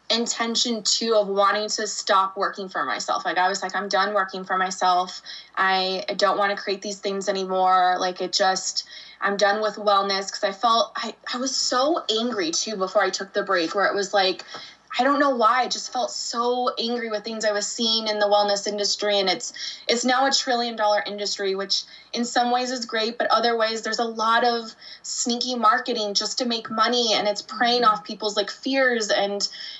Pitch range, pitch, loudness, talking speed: 195-235 Hz, 210 Hz, -22 LUFS, 210 wpm